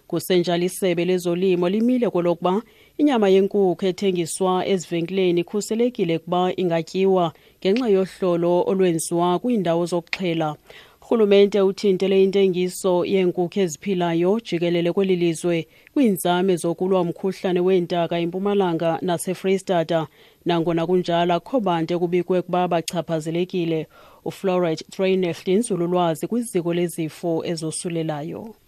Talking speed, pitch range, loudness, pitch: 90 wpm, 170-190 Hz, -21 LUFS, 180 Hz